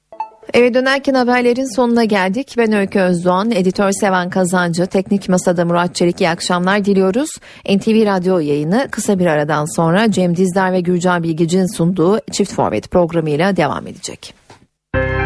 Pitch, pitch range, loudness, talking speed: 185 Hz, 175-220 Hz, -15 LUFS, 140 wpm